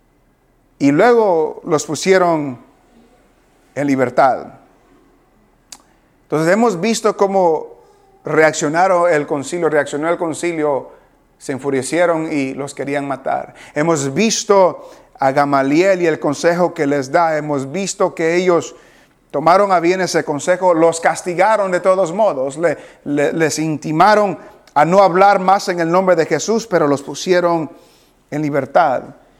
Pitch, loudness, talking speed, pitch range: 170 Hz, -15 LUFS, 125 wpm, 145-190 Hz